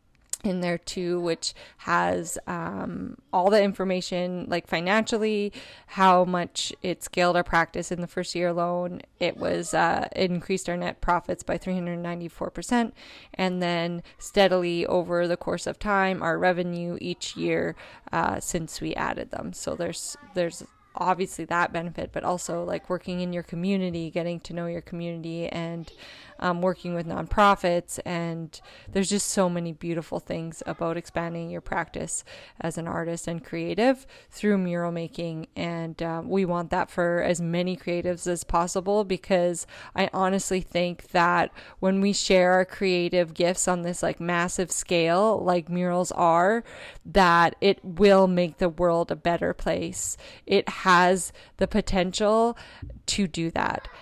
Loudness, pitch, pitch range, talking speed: -26 LUFS, 175 Hz, 170-190 Hz, 155 wpm